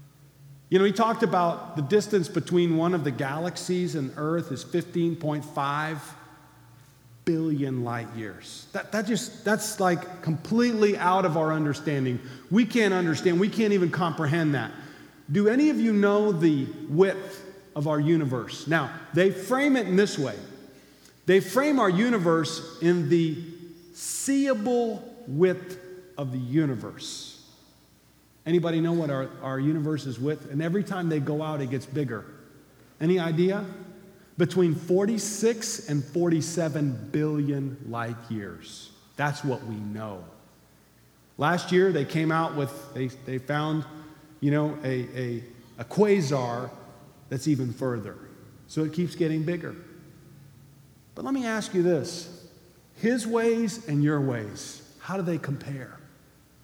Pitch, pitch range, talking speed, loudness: 160 Hz, 140-185 Hz, 140 wpm, -26 LUFS